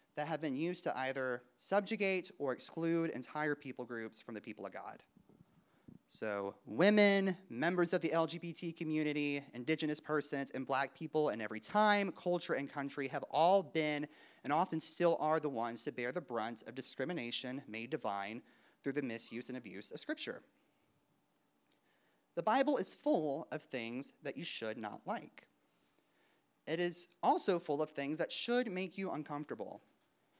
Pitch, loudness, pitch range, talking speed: 150 Hz, -37 LUFS, 130-175 Hz, 160 wpm